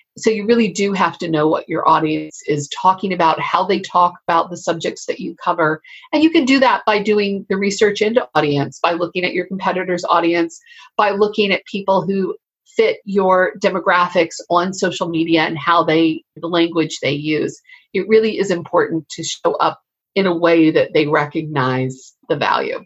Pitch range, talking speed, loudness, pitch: 160-210 Hz, 190 wpm, -17 LUFS, 180 Hz